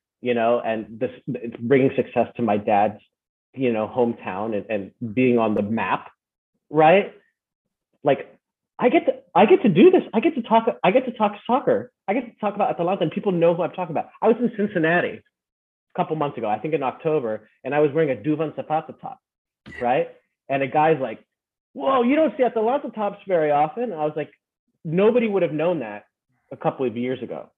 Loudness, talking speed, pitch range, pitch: -22 LUFS, 210 wpm, 125-205 Hz, 155 Hz